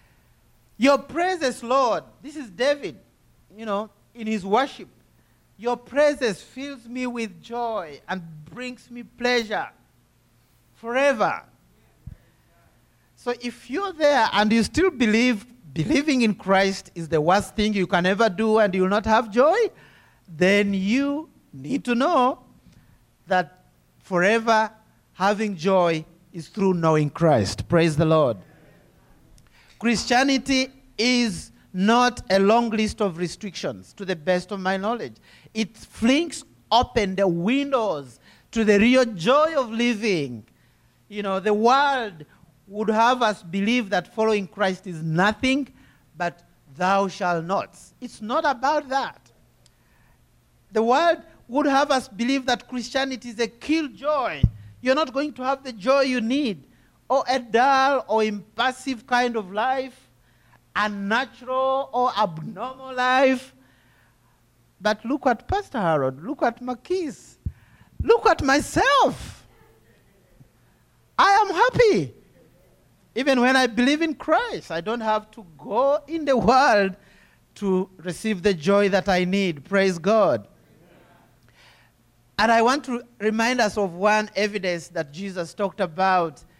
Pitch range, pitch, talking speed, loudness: 190-260 Hz, 225 Hz, 135 wpm, -22 LUFS